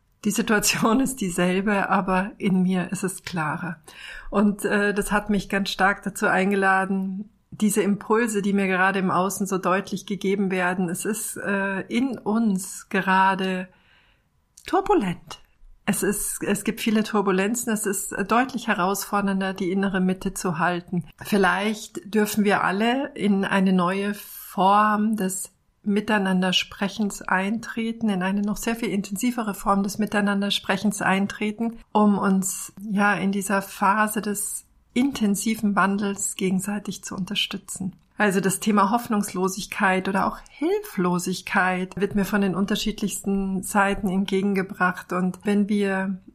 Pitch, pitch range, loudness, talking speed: 200 Hz, 190-210 Hz, -23 LUFS, 135 wpm